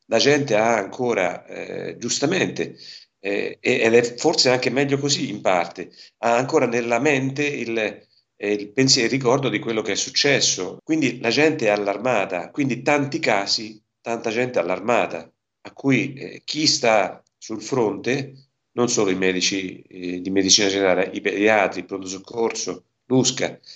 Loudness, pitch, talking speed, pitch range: -21 LUFS, 115 Hz, 155 wpm, 100-135 Hz